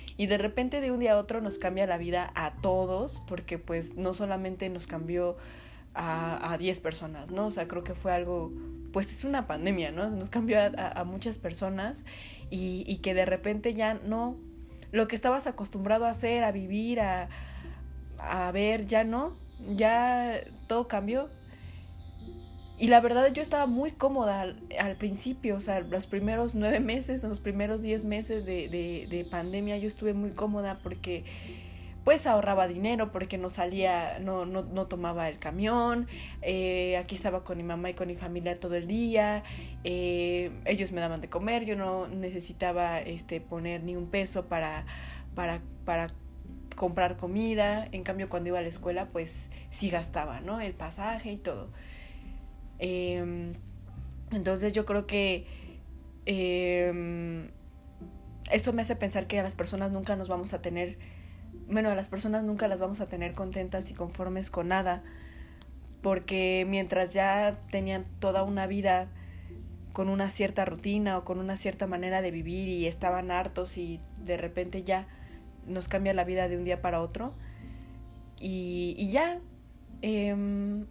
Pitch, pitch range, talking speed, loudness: 185 Hz, 165-205 Hz, 165 wpm, -31 LUFS